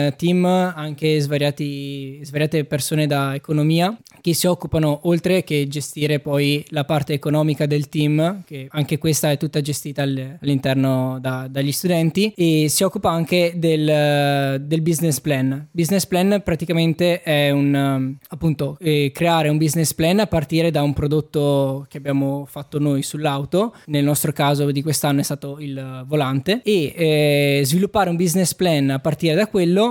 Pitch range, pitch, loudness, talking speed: 140-165 Hz, 150 Hz, -19 LUFS, 155 wpm